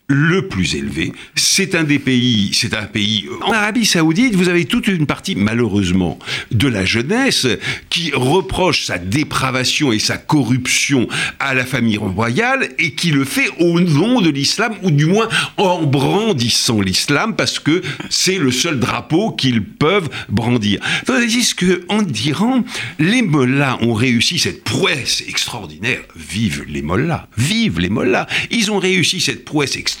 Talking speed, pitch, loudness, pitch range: 160 wpm, 145 Hz, -15 LUFS, 115-185 Hz